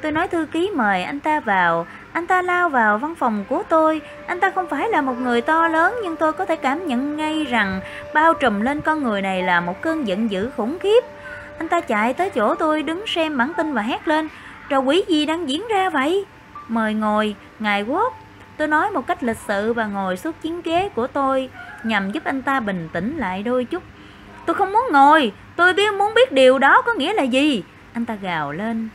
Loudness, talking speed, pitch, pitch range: -20 LUFS, 230 wpm, 295 Hz, 230-335 Hz